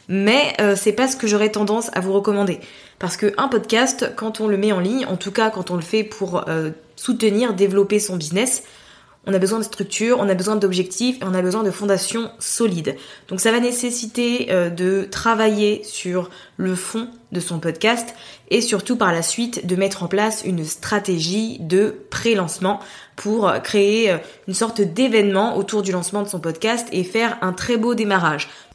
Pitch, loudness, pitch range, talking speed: 205 Hz, -20 LUFS, 185-225 Hz, 190 wpm